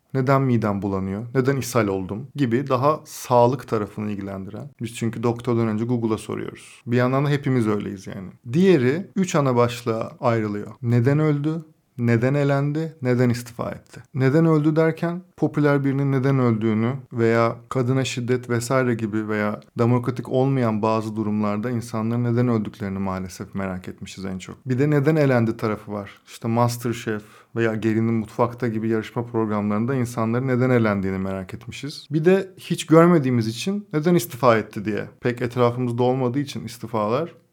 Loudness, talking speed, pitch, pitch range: -22 LUFS, 150 wpm, 120 Hz, 110-135 Hz